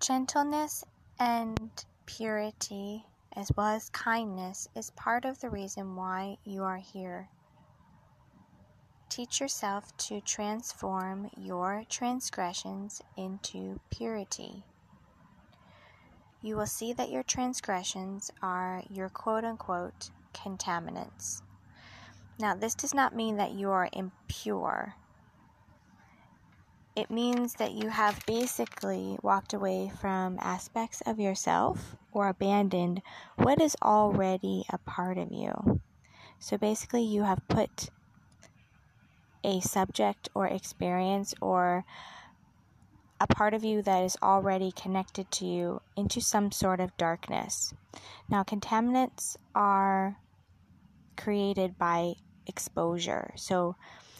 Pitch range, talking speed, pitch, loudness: 180-215 Hz, 105 wpm, 195 Hz, -32 LUFS